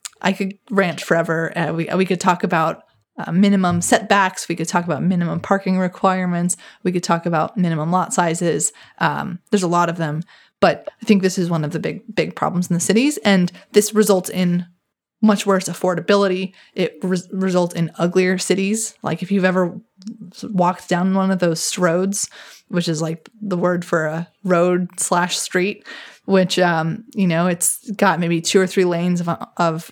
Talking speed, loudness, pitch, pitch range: 185 wpm, -19 LUFS, 180 Hz, 170-195 Hz